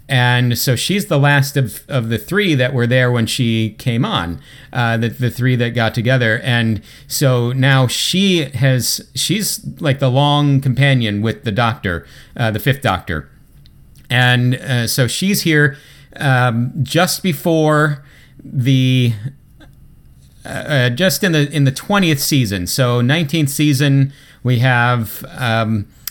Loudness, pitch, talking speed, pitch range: -15 LUFS, 130 Hz, 145 wpm, 120-145 Hz